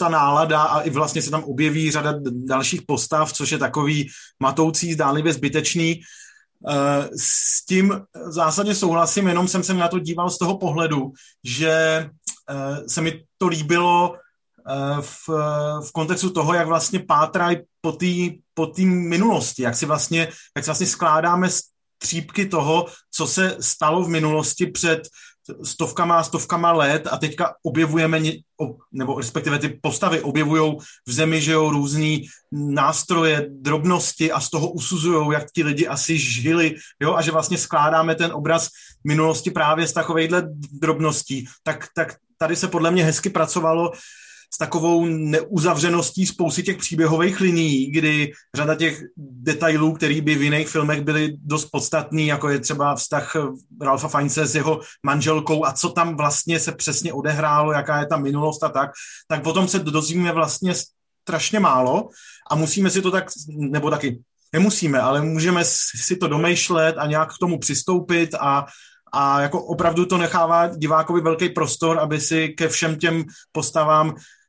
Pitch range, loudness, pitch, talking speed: 150-170 Hz, -20 LUFS, 160 Hz, 150 wpm